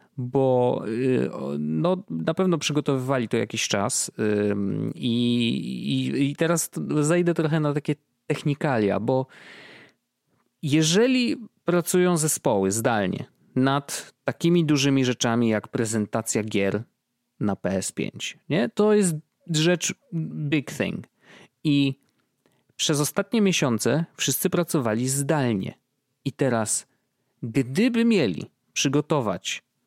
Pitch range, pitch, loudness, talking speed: 120-165 Hz, 140 Hz, -24 LUFS, 100 wpm